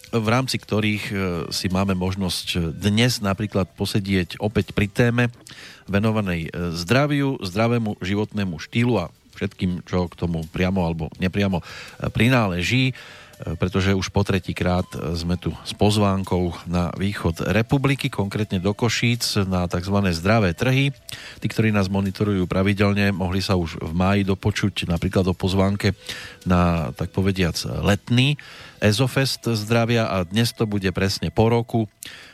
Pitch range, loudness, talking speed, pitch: 90-110 Hz, -22 LUFS, 130 wpm, 100 Hz